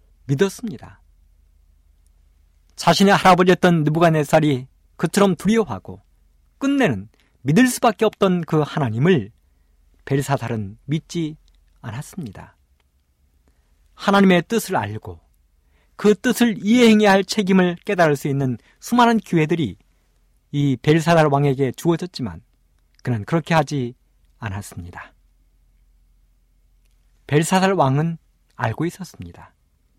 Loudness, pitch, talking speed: -19 LUFS, 135 Hz, 245 characters per minute